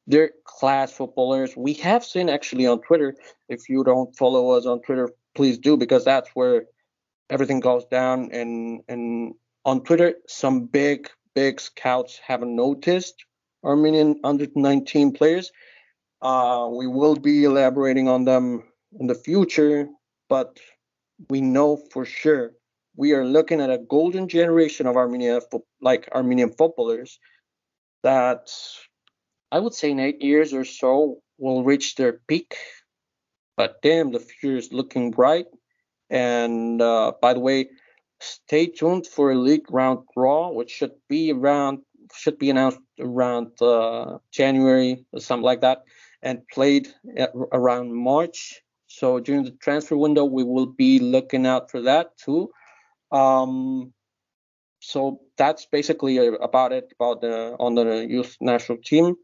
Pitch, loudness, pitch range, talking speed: 135 Hz, -21 LUFS, 125-150 Hz, 145 wpm